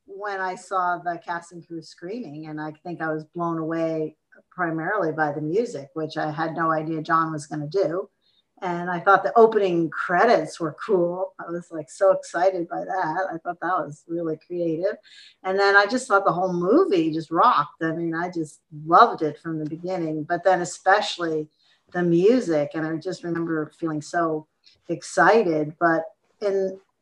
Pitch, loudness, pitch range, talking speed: 170 Hz, -23 LUFS, 160-185 Hz, 180 wpm